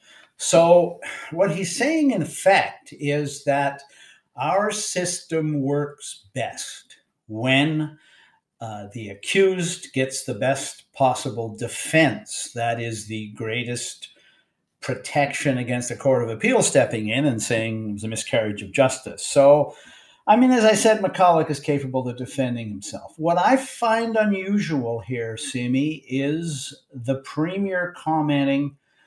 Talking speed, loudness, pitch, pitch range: 130 wpm, -22 LUFS, 140 Hz, 120-175 Hz